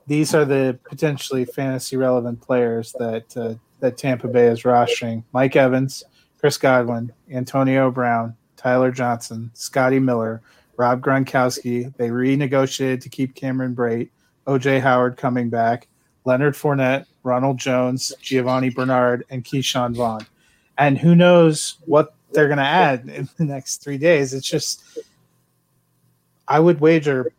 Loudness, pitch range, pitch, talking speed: -19 LUFS, 120-140 Hz, 130 Hz, 140 wpm